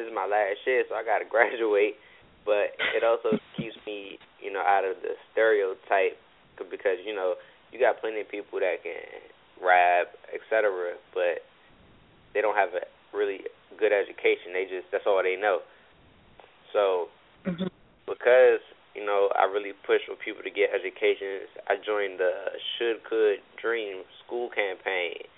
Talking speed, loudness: 155 wpm, -27 LUFS